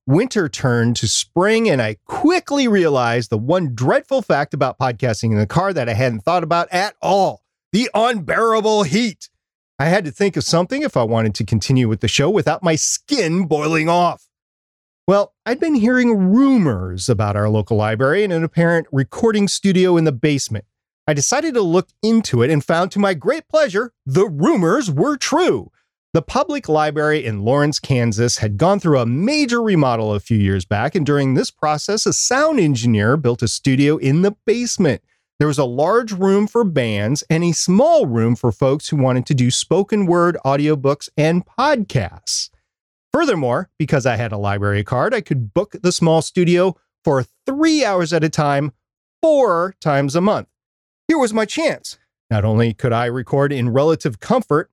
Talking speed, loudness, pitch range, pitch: 180 wpm, -17 LUFS, 125-200 Hz, 155 Hz